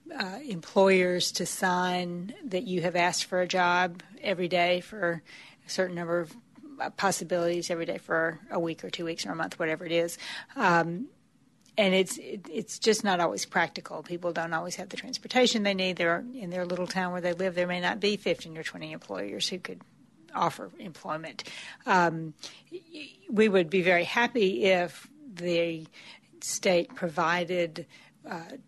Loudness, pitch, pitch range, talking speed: -28 LUFS, 180 Hz, 175-200 Hz, 170 wpm